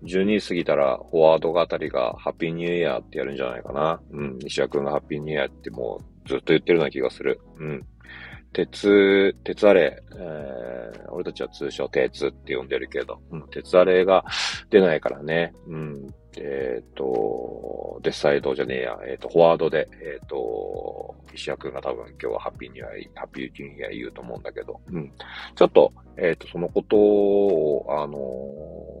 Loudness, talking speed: -23 LUFS, 390 characters per minute